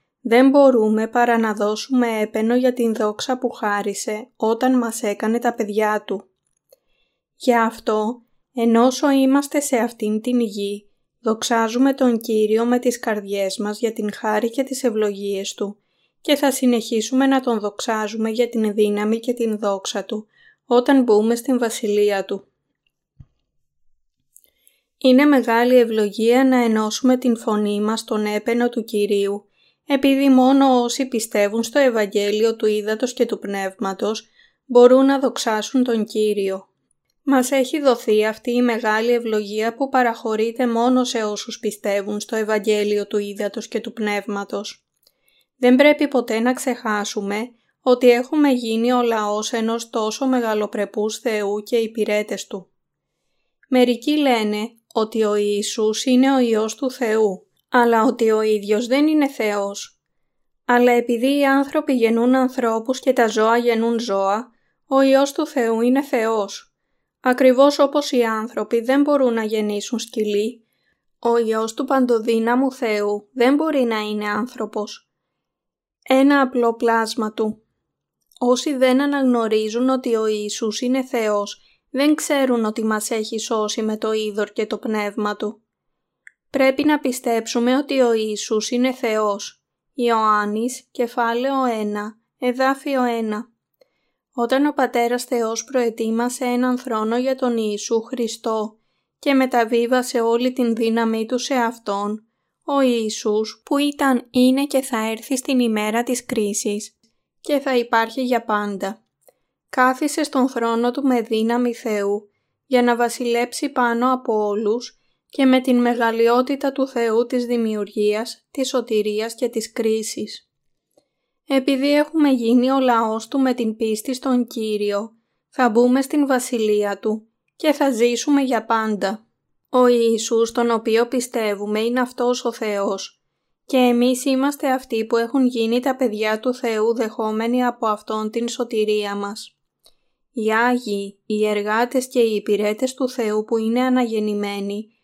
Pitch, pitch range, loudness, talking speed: 230 Hz, 215-255 Hz, -19 LUFS, 140 wpm